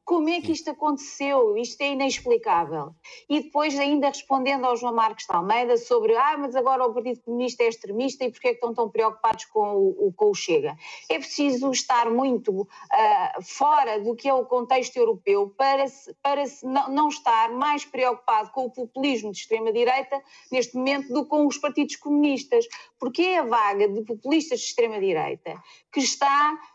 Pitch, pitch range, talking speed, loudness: 275 Hz, 240-300 Hz, 185 wpm, -24 LUFS